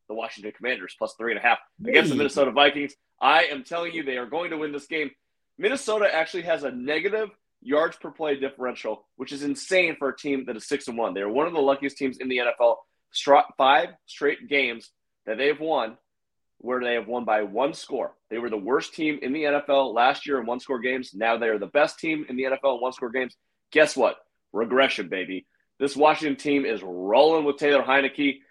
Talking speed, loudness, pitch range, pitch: 225 wpm, -24 LUFS, 125-150 Hz, 140 Hz